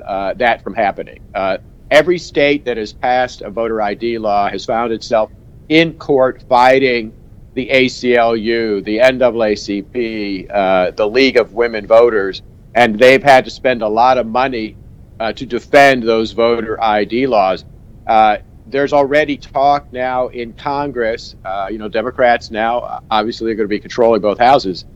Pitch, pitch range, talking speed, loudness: 115 Hz, 110-130 Hz, 160 wpm, -14 LUFS